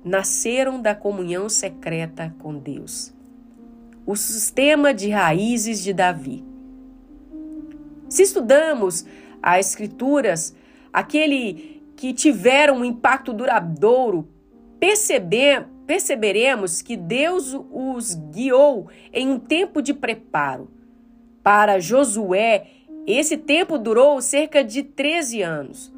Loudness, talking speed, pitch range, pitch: -19 LUFS, 95 wpm, 210-285 Hz, 255 Hz